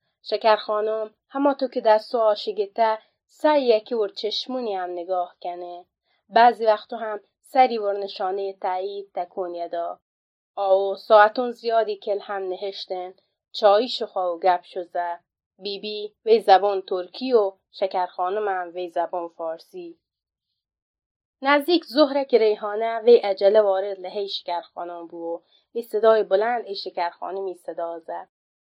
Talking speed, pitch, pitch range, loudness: 130 wpm, 200 Hz, 185-225 Hz, -23 LUFS